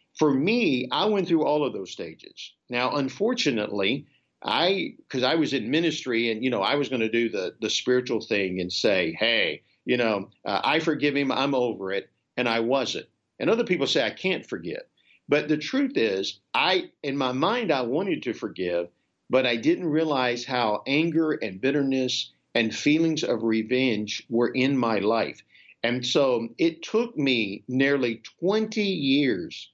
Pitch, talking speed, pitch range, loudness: 135 Hz, 175 wpm, 115-160 Hz, -25 LUFS